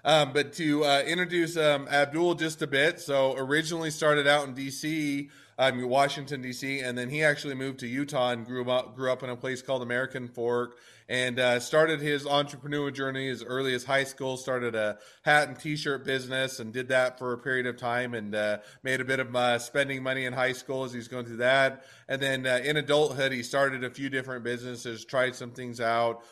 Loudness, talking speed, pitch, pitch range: -28 LUFS, 215 wpm, 130 Hz, 125-145 Hz